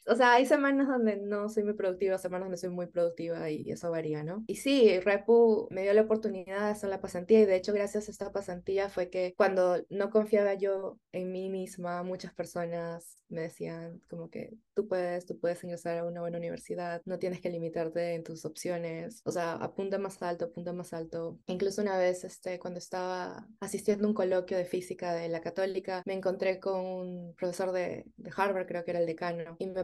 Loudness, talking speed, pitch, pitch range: -32 LUFS, 215 wpm, 185 Hz, 175-200 Hz